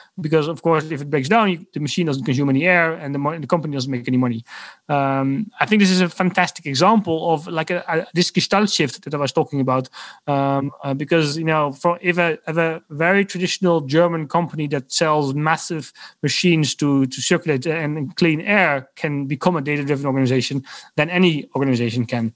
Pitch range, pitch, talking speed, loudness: 140-170 Hz, 155 Hz, 200 wpm, -19 LUFS